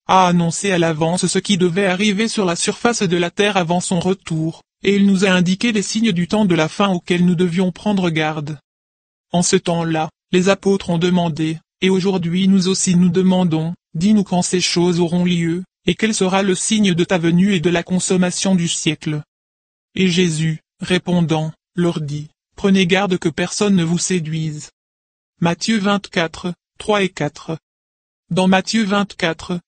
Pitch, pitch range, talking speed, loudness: 180 Hz, 165-190 Hz, 175 wpm, -17 LUFS